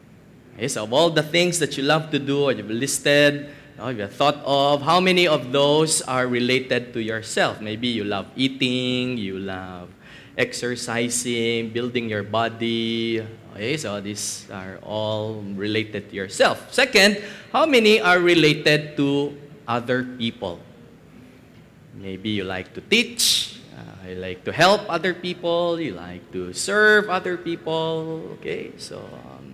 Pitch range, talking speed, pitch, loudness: 105-155 Hz, 145 wpm, 125 Hz, -21 LUFS